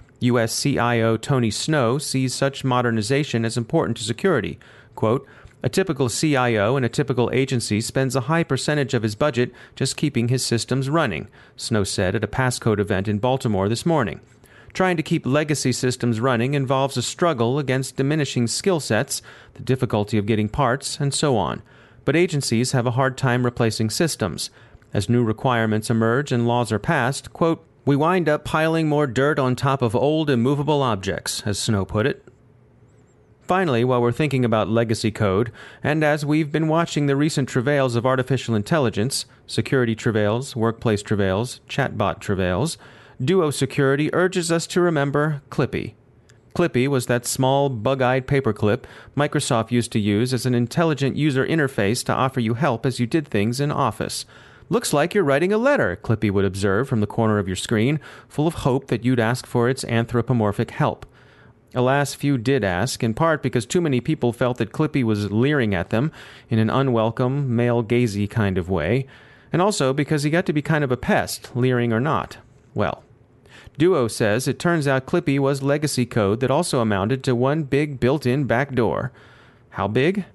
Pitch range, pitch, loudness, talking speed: 115-140 Hz, 125 Hz, -21 LUFS, 180 wpm